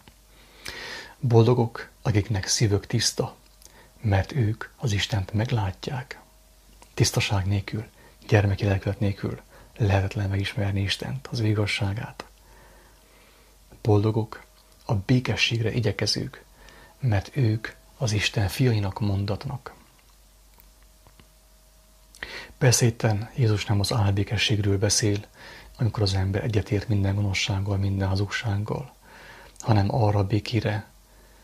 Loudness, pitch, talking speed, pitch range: -25 LUFS, 105 Hz, 90 wpm, 100-115 Hz